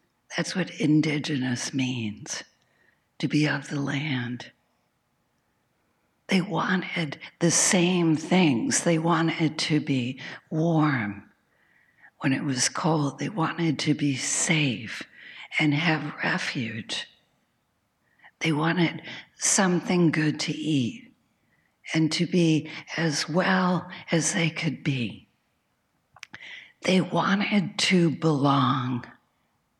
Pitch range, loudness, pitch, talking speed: 140-170 Hz, -25 LUFS, 155 Hz, 100 wpm